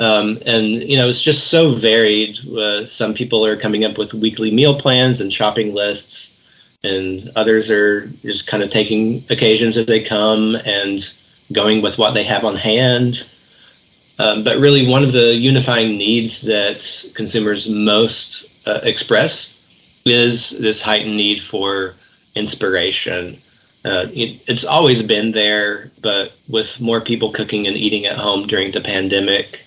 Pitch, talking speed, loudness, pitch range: 110 Hz, 155 wpm, -15 LUFS, 105-115 Hz